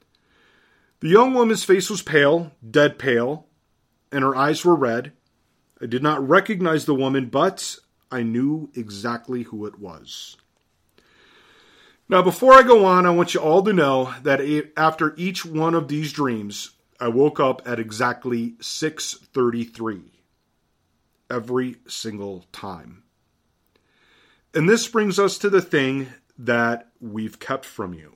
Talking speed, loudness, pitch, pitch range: 140 wpm, -20 LUFS, 140 Hz, 120-175 Hz